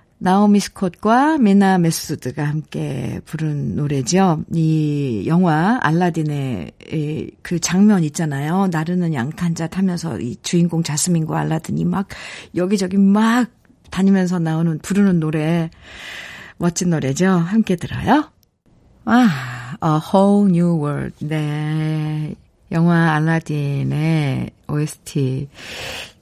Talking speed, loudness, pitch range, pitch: 245 characters per minute, -18 LUFS, 150-190 Hz, 165 Hz